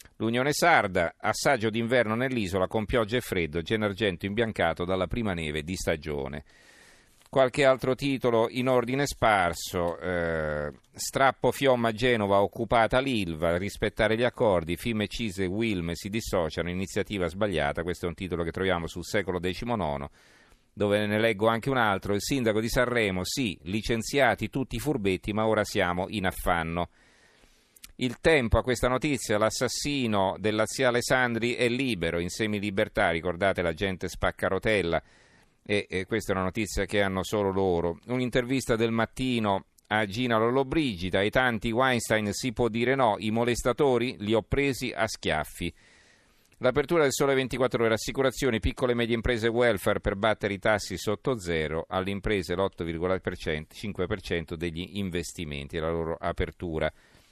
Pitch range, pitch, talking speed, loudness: 90-120 Hz, 105 Hz, 150 wpm, -27 LUFS